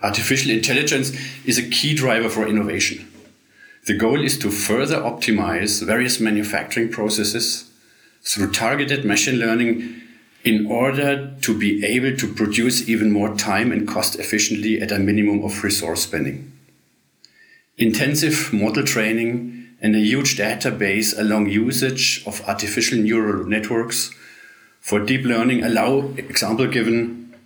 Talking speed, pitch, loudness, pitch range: 130 wpm, 115 Hz, -19 LUFS, 105-125 Hz